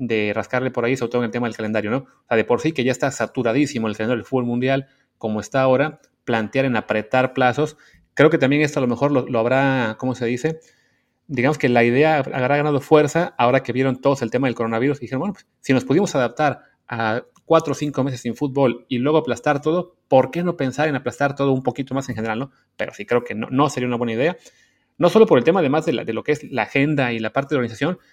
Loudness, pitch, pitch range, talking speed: -20 LUFS, 130 Hz, 120-145 Hz, 260 wpm